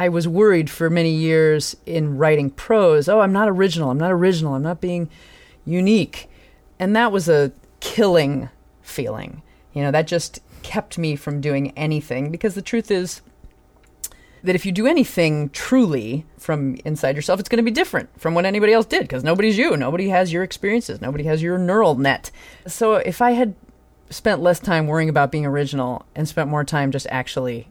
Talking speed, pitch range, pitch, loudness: 190 wpm, 145-190 Hz, 160 Hz, -19 LUFS